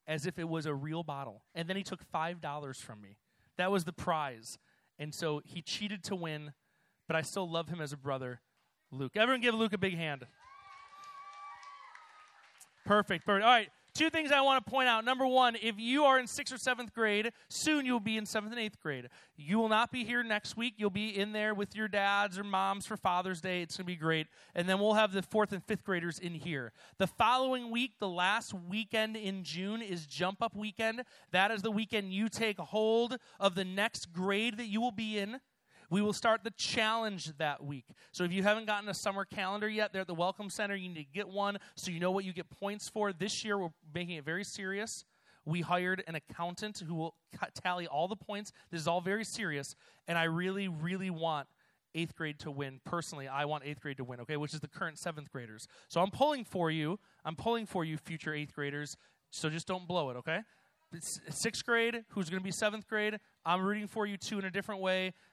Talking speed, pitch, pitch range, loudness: 225 wpm, 195 Hz, 165-220 Hz, -34 LUFS